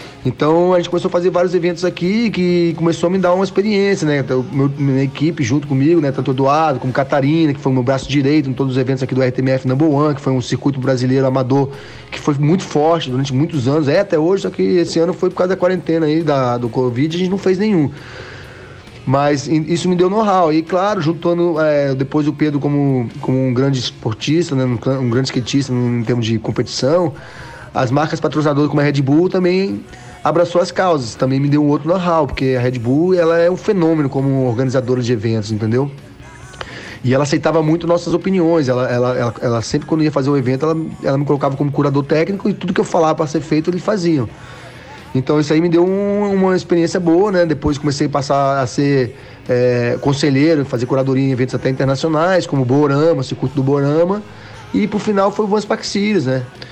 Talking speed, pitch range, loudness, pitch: 220 wpm, 130-170 Hz, -16 LUFS, 145 Hz